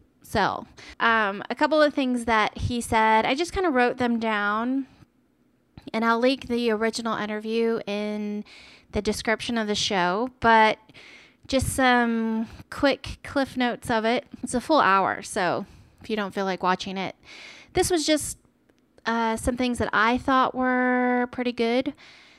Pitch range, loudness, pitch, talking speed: 215-255 Hz, -24 LUFS, 230 Hz, 160 wpm